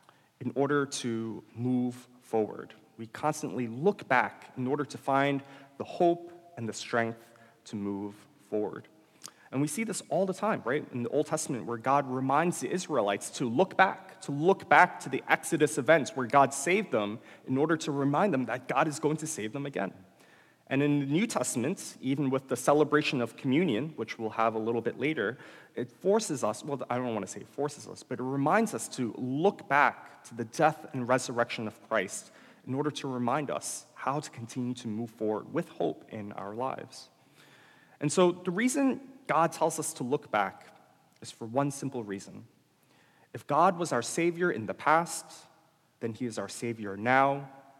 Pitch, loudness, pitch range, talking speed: 135 Hz, -30 LUFS, 120-155 Hz, 195 wpm